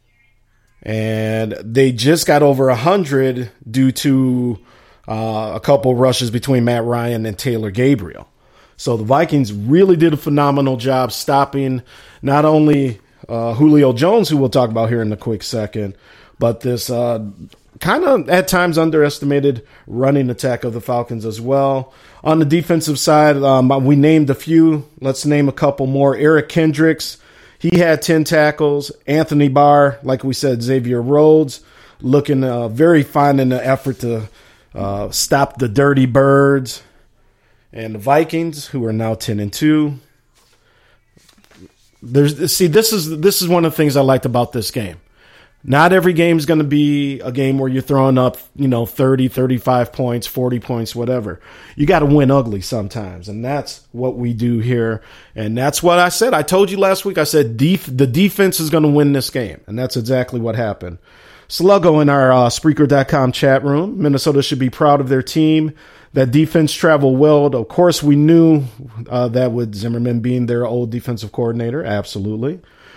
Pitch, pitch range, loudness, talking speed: 135 Hz, 120-150 Hz, -15 LUFS, 175 wpm